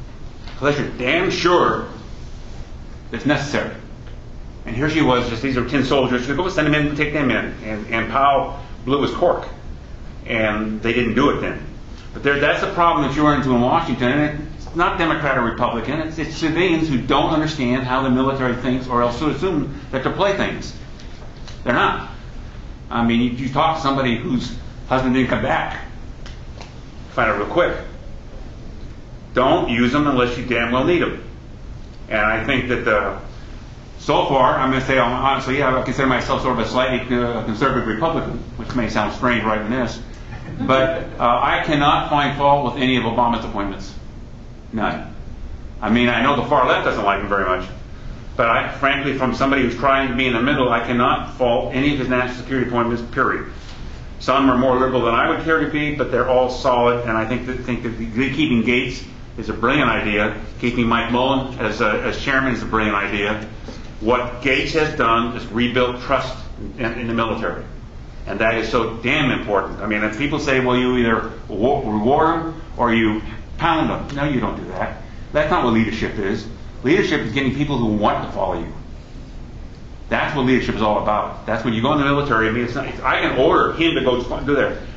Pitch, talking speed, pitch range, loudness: 125 Hz, 205 wpm, 115-135 Hz, -19 LUFS